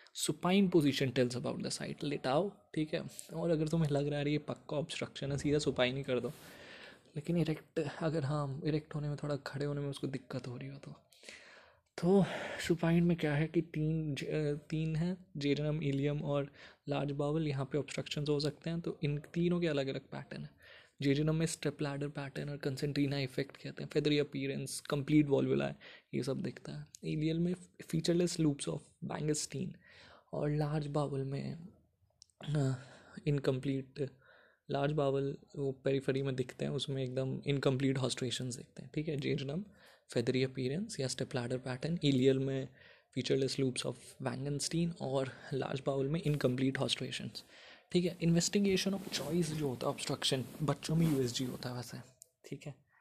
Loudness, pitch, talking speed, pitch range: -36 LUFS, 145 Hz, 170 wpm, 135-160 Hz